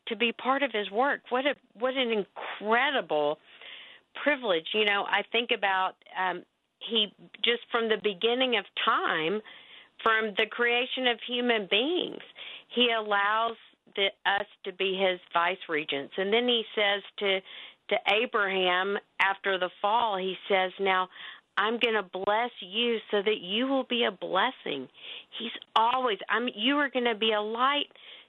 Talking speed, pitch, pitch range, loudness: 160 wpm, 220 Hz, 195-240 Hz, -28 LUFS